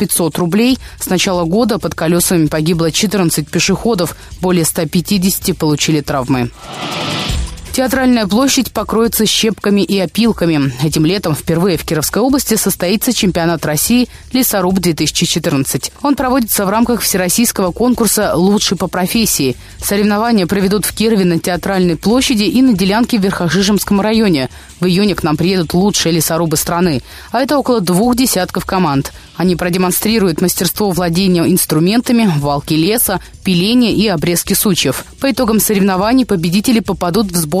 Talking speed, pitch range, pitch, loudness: 135 wpm, 170-220 Hz, 185 Hz, -13 LUFS